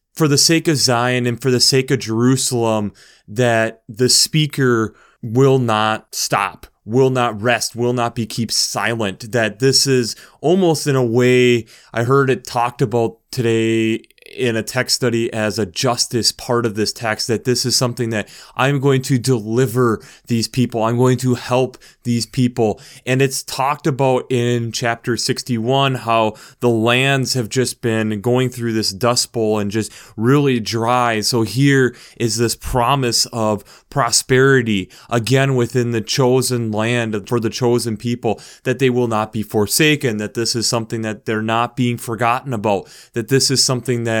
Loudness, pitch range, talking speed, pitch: -17 LUFS, 115-130 Hz, 170 wpm, 120 Hz